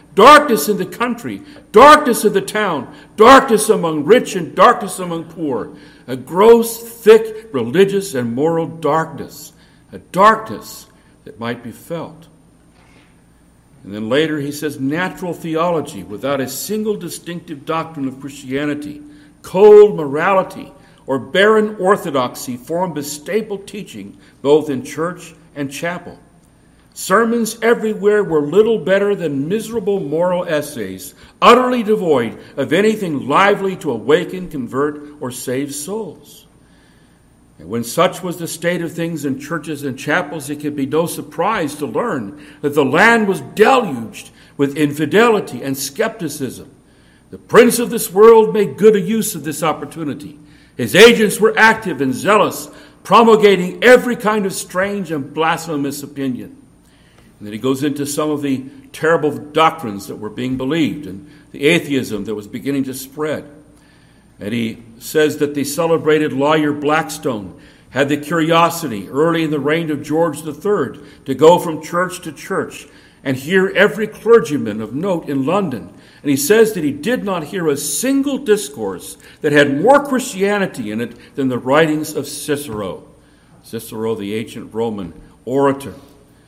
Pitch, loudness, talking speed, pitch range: 160 Hz, -15 LUFS, 145 wpm, 140-200 Hz